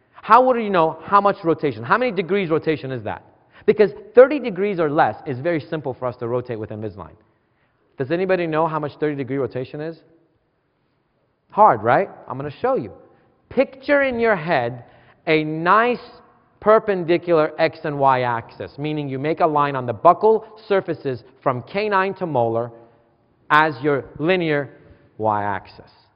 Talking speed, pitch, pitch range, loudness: 165 wpm, 155 Hz, 125-190 Hz, -20 LUFS